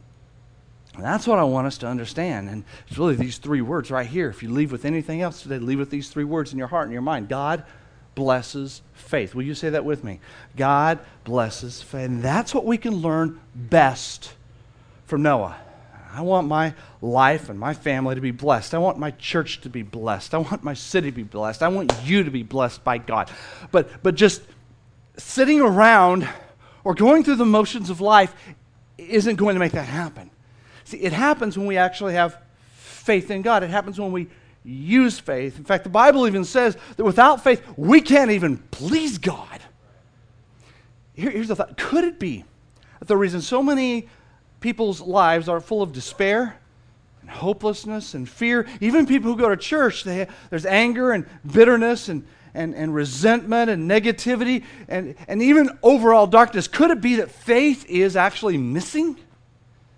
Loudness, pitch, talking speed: -20 LUFS, 160 Hz, 185 wpm